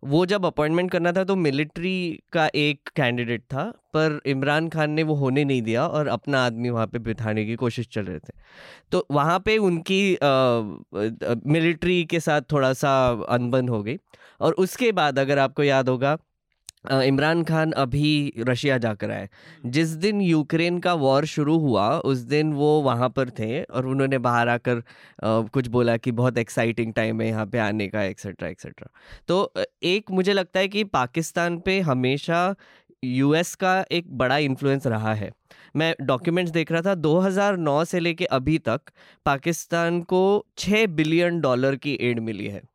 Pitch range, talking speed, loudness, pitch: 125-170 Hz, 170 wpm, -23 LUFS, 145 Hz